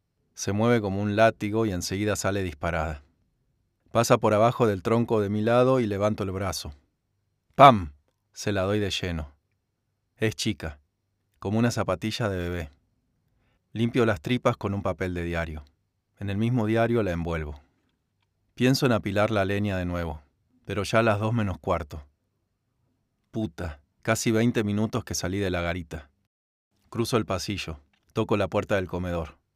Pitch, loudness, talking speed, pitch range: 105 Hz, -26 LUFS, 160 wpm, 90-115 Hz